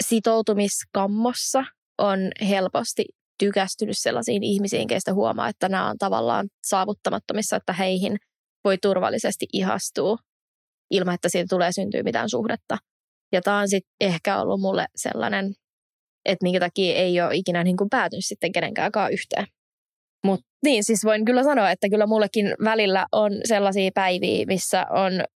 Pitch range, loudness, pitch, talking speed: 190-215 Hz, -23 LUFS, 200 Hz, 140 wpm